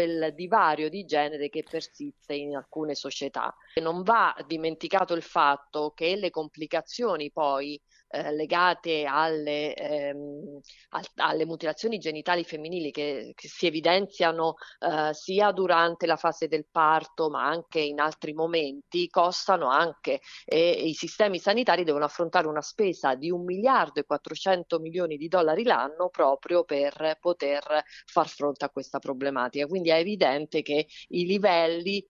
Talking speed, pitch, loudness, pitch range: 140 wpm, 160 Hz, -27 LUFS, 150-175 Hz